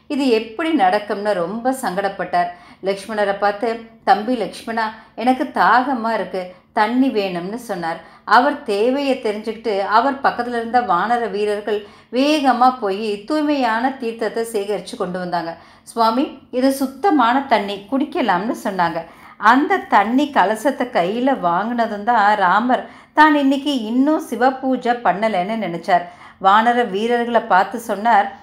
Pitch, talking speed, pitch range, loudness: 225 Hz, 115 wpm, 200-255 Hz, -18 LUFS